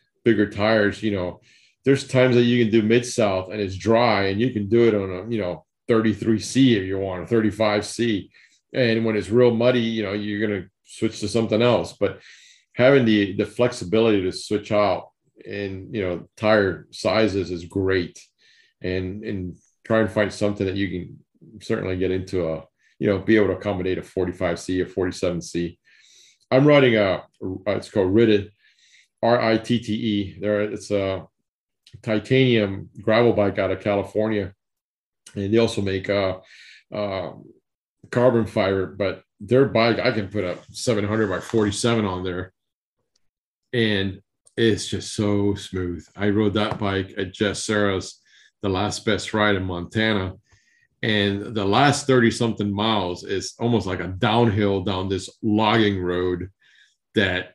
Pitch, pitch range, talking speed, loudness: 105 Hz, 95-115 Hz, 165 wpm, -22 LUFS